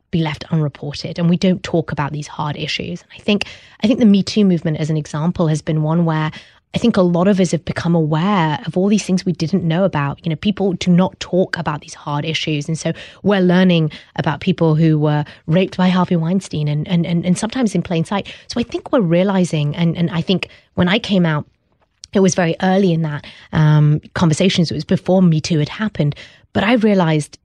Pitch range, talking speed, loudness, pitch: 155-185 Hz, 230 wpm, -17 LUFS, 170 Hz